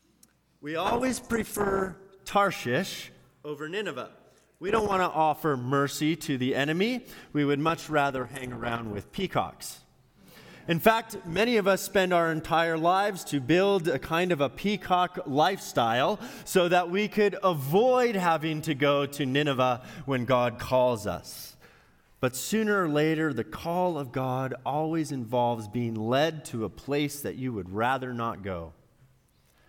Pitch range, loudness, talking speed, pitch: 130-185 Hz, -27 LUFS, 150 wpm, 155 Hz